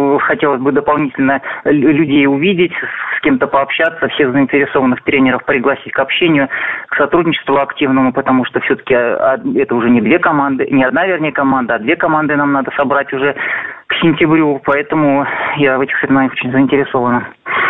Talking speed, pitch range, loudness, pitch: 155 wpm, 135-150 Hz, -13 LUFS, 140 Hz